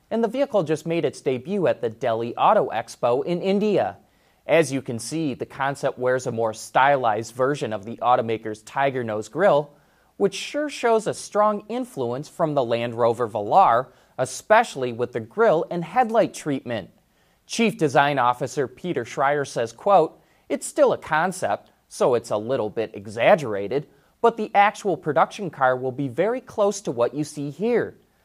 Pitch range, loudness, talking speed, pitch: 125-200 Hz, -23 LUFS, 170 wpm, 145 Hz